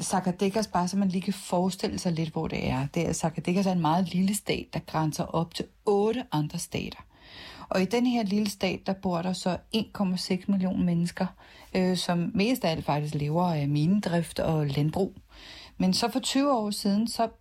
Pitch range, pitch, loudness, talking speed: 170-200 Hz, 185 Hz, -28 LUFS, 200 wpm